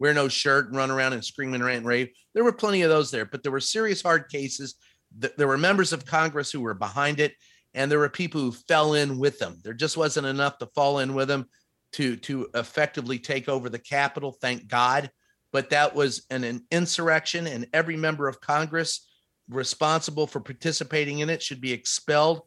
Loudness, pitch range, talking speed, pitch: -25 LUFS, 130-155 Hz, 210 wpm, 140 Hz